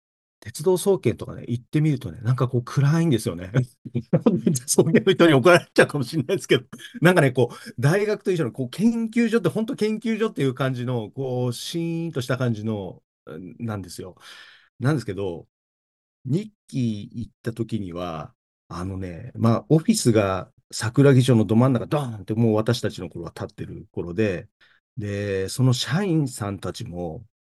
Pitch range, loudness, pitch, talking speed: 110-165 Hz, -23 LUFS, 125 Hz, 340 characters per minute